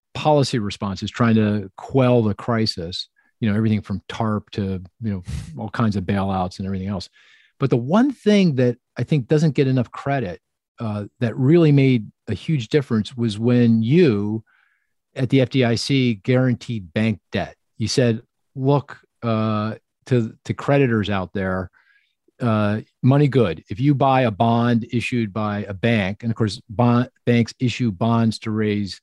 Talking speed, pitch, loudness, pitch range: 155 wpm, 115 Hz, -21 LUFS, 105-130 Hz